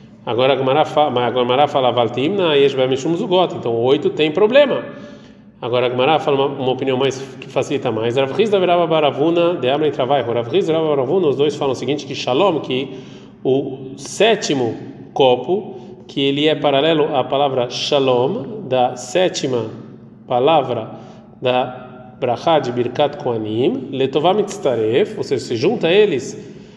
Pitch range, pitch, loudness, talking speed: 125-165 Hz, 140 Hz, -17 LUFS, 100 wpm